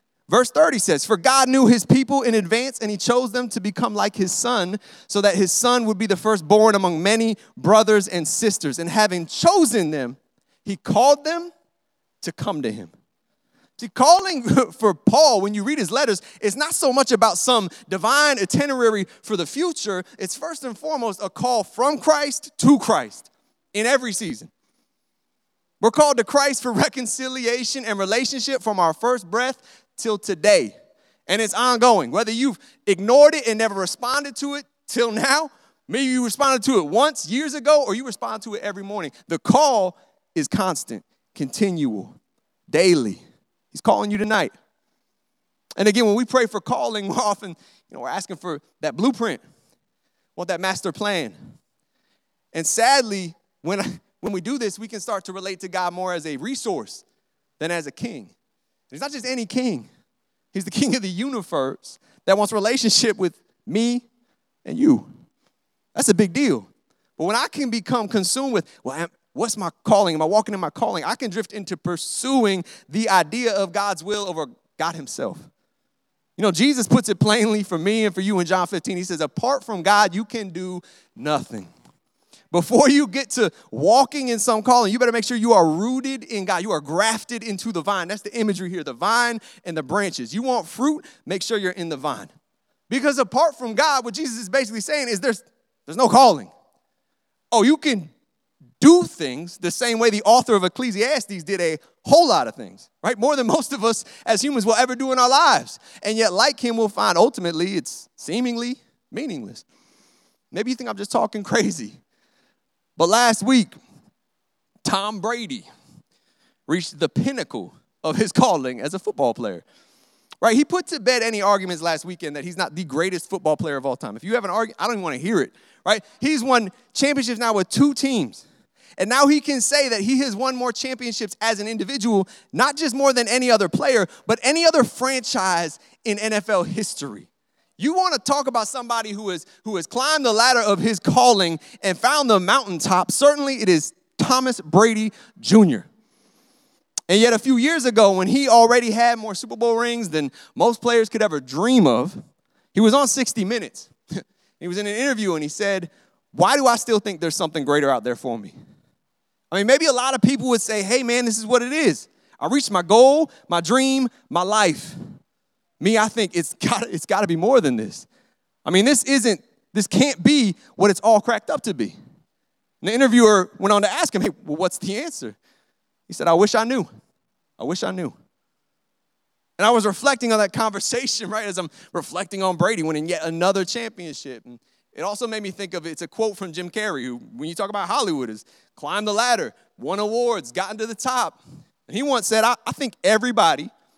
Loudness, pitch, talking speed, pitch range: -20 LUFS, 225 Hz, 195 wpm, 195-255 Hz